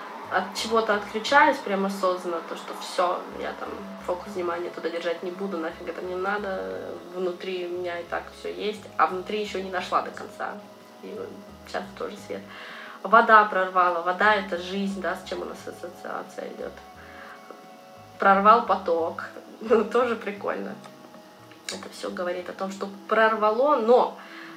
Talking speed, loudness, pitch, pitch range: 155 wpm, -25 LUFS, 190 Hz, 180-215 Hz